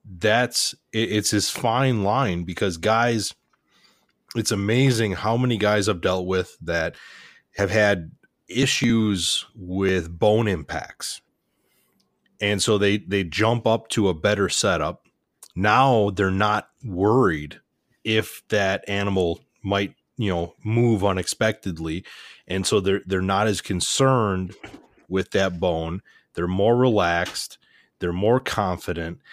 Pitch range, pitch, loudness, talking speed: 95-110 Hz, 100 Hz, -22 LUFS, 125 wpm